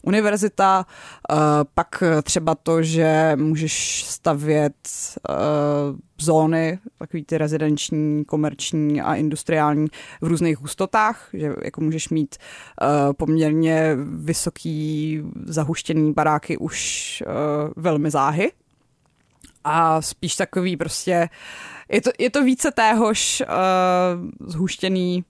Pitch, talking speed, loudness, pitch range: 160 Hz, 95 wpm, -21 LUFS, 150-180 Hz